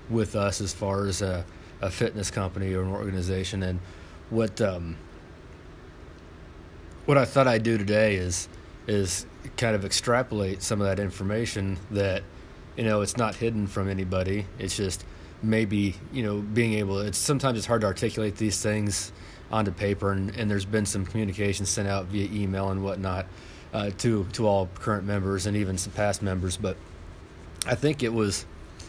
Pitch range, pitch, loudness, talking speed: 90-105 Hz, 100 Hz, -27 LUFS, 170 wpm